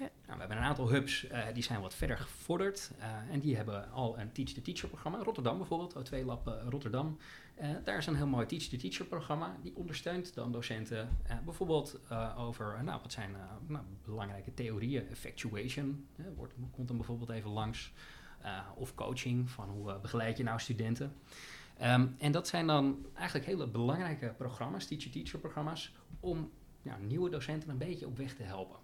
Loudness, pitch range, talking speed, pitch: -39 LUFS, 115-150 Hz, 195 wpm, 130 Hz